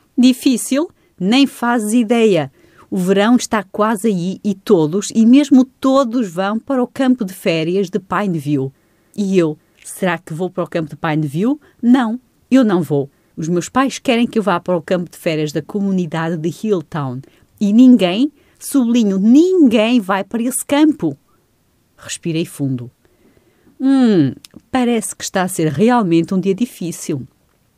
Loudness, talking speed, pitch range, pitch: -16 LUFS, 155 wpm, 170-245 Hz, 200 Hz